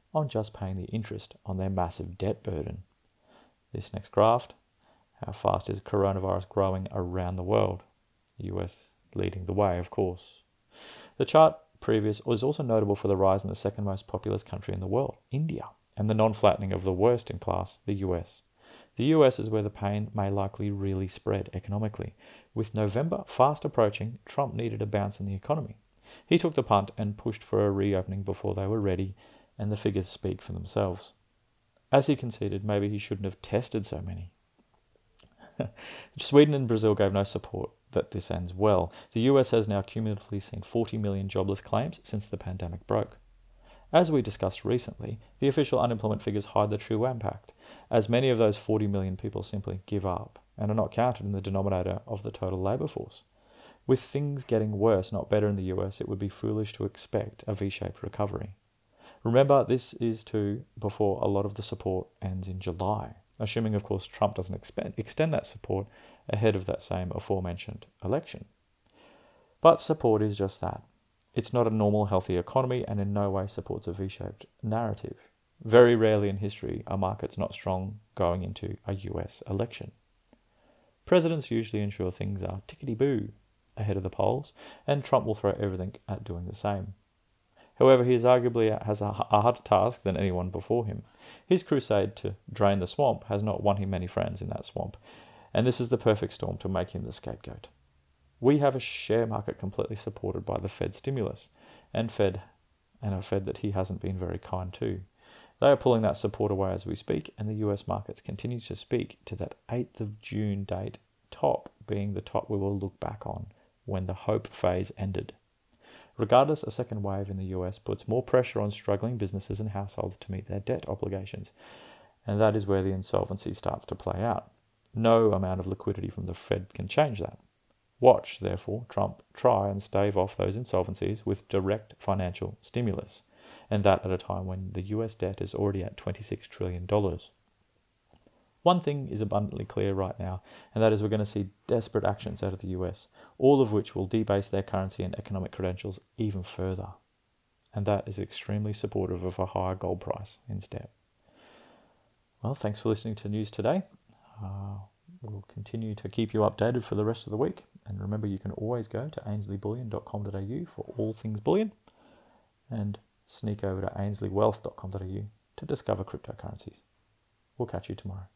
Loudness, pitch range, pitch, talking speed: -29 LUFS, 95-115 Hz, 105 Hz, 185 wpm